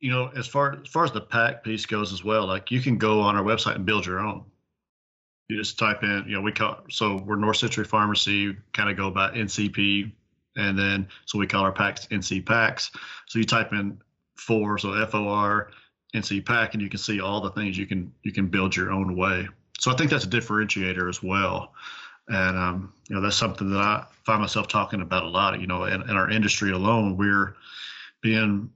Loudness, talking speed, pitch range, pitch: -25 LUFS, 225 wpm, 100-110 Hz, 105 Hz